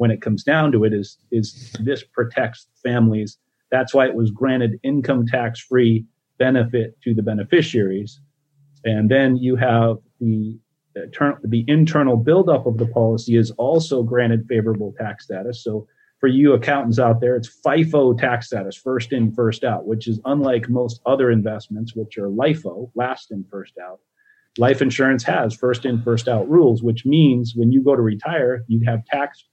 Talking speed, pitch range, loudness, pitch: 170 wpm, 115-135 Hz, -19 LUFS, 120 Hz